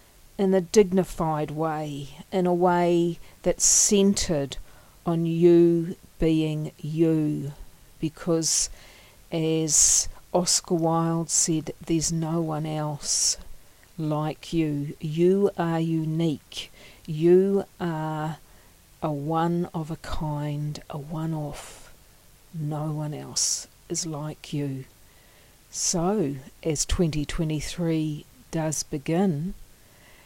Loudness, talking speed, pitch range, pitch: -25 LUFS, 95 wpm, 150-170 Hz, 160 Hz